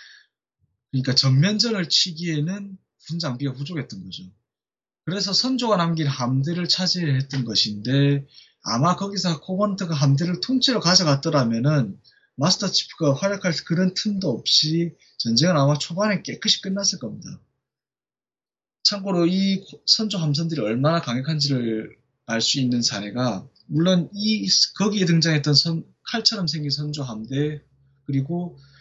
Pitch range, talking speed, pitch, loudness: 135-190 Hz, 295 characters per minute, 160 Hz, -21 LUFS